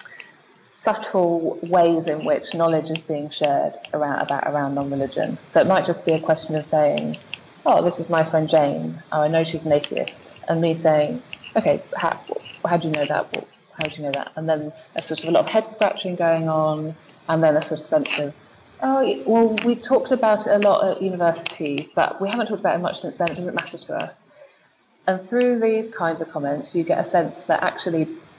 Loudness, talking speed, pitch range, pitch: -22 LUFS, 220 wpm, 155-190 Hz, 165 Hz